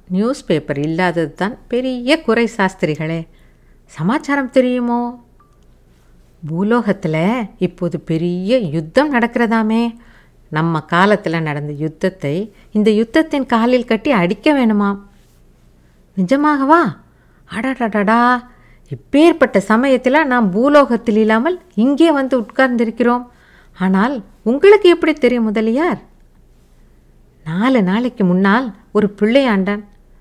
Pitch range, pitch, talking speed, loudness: 180-255 Hz, 225 Hz, 85 wpm, -15 LUFS